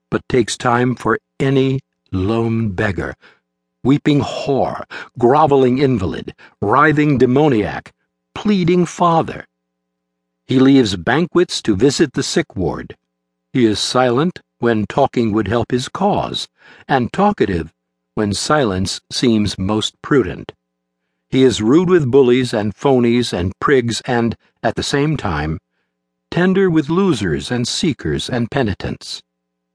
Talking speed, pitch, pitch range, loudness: 120 wpm, 120 Hz, 90-140 Hz, -16 LUFS